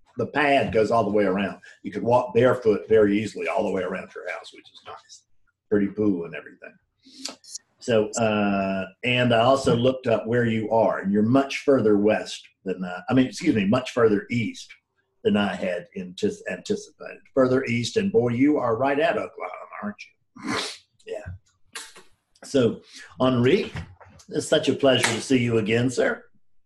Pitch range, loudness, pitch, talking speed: 105-130 Hz, -23 LUFS, 115 Hz, 175 wpm